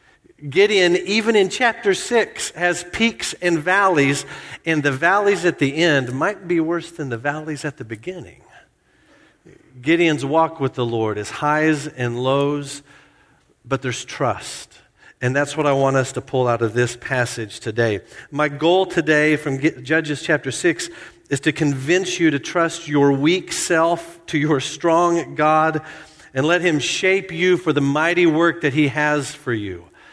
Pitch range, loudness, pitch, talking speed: 140-175 Hz, -19 LUFS, 155 Hz, 165 wpm